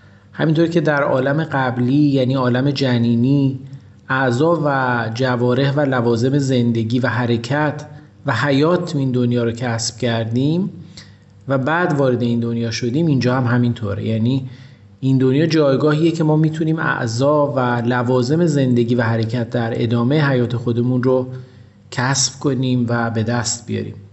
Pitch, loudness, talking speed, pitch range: 130 Hz, -17 LUFS, 140 wpm, 120-140 Hz